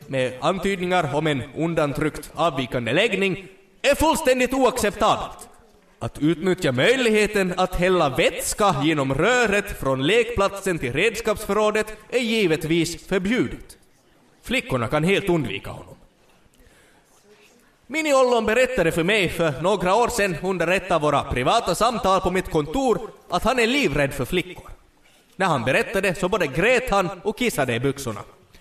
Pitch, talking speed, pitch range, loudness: 185 Hz, 135 wpm, 150-215 Hz, -21 LUFS